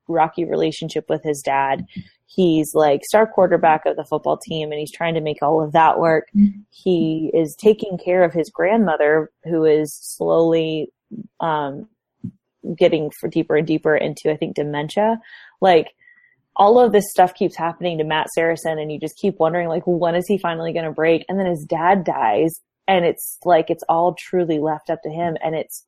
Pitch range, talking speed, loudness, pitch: 155-185 Hz, 190 wpm, -19 LUFS, 165 Hz